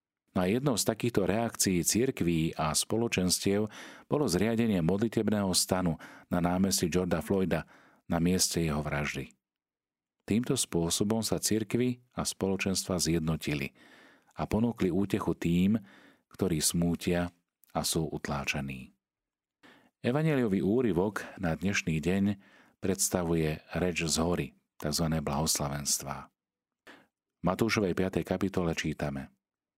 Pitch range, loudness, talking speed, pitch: 80-100 Hz, -30 LUFS, 105 wpm, 90 Hz